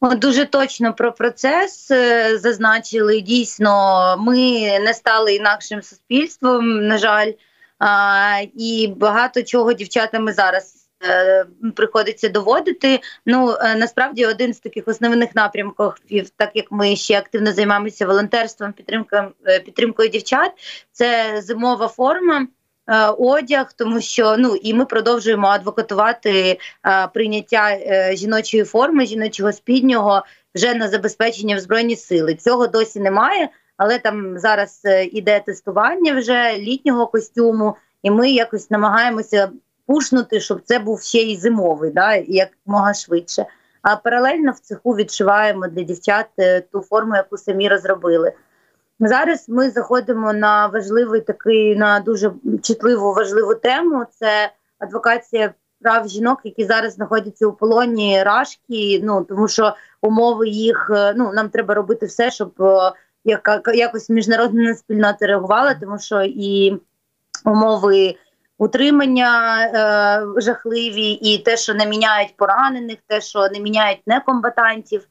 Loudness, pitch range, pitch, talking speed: -17 LUFS, 205-235 Hz, 220 Hz, 130 wpm